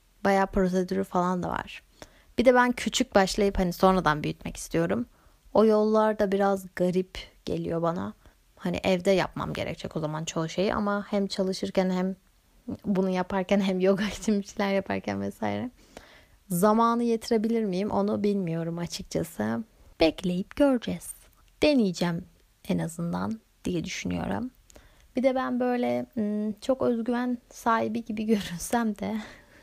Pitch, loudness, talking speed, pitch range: 195 Hz, -27 LUFS, 130 wpm, 180-220 Hz